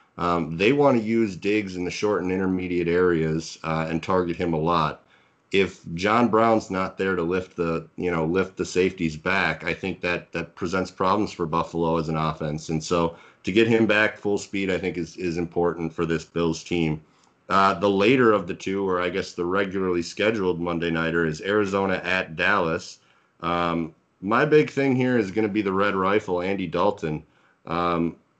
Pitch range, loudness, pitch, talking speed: 85-100 Hz, -24 LUFS, 90 Hz, 195 wpm